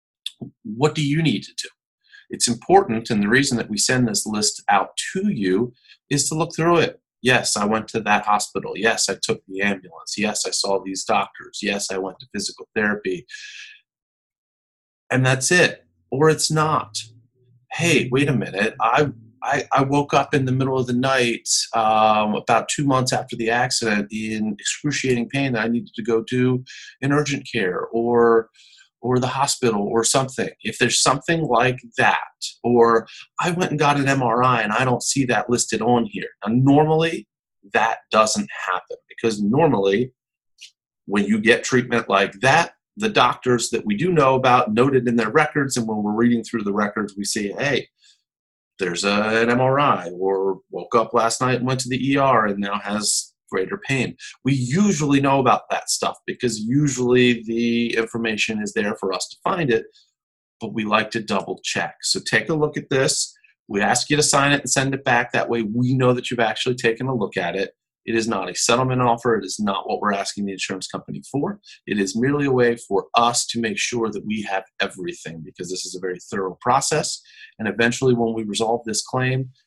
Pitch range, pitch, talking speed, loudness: 110-135 Hz, 120 Hz, 195 wpm, -20 LUFS